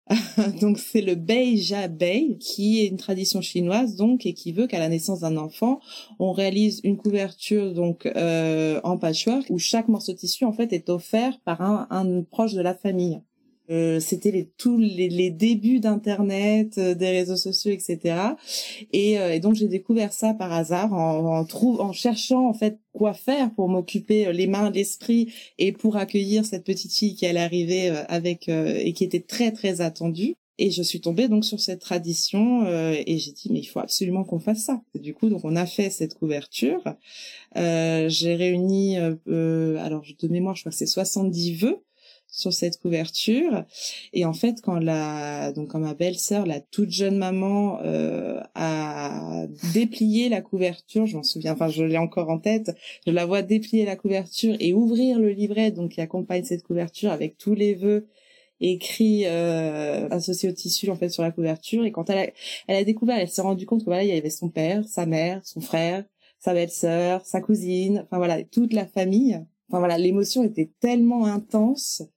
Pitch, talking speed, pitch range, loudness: 190 Hz, 195 wpm, 170-215 Hz, -24 LUFS